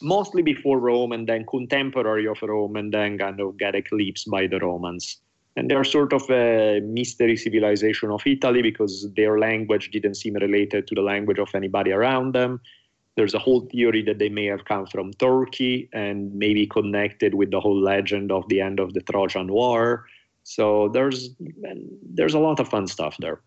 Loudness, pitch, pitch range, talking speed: -22 LUFS, 110 Hz, 100-125 Hz, 185 wpm